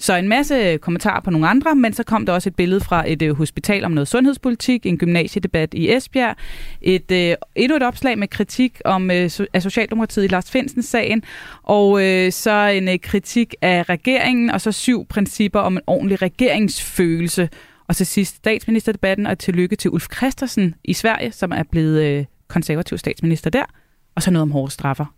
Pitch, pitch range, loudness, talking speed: 195 Hz, 175-225 Hz, -18 LUFS, 180 wpm